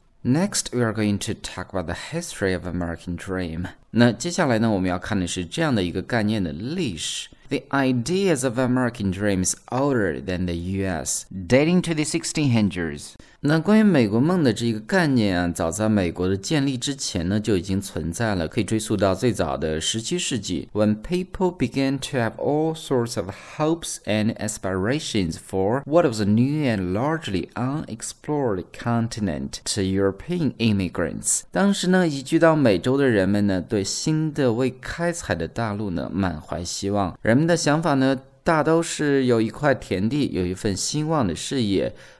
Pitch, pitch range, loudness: 115 Hz, 95-145 Hz, -23 LUFS